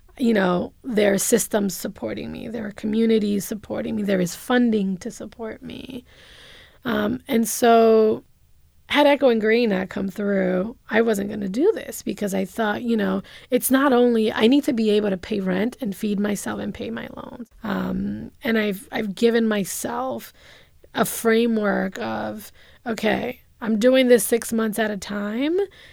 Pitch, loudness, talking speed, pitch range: 220 Hz, -22 LUFS, 175 wpm, 205-240 Hz